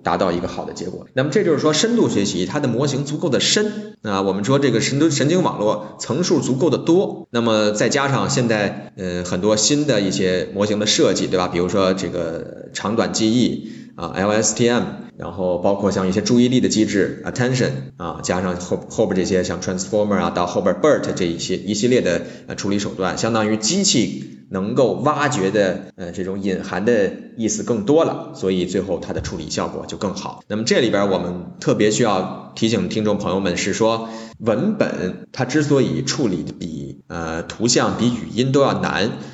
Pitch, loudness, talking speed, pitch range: 105 Hz, -19 LUFS, 325 characters per minute, 90-125 Hz